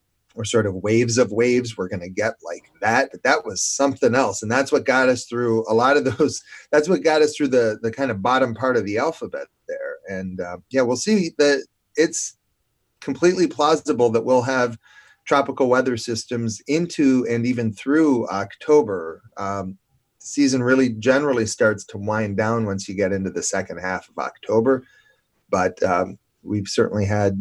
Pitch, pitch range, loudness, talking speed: 125 Hz, 110-140 Hz, -21 LUFS, 180 wpm